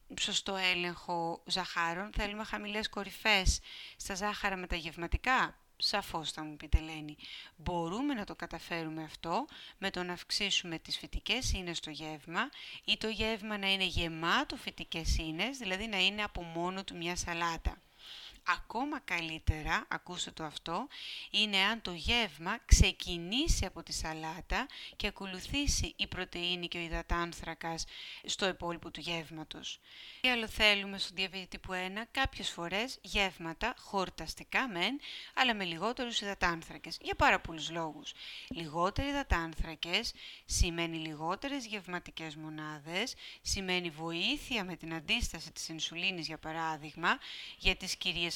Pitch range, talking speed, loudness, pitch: 165-210 Hz, 135 wpm, -34 LUFS, 180 Hz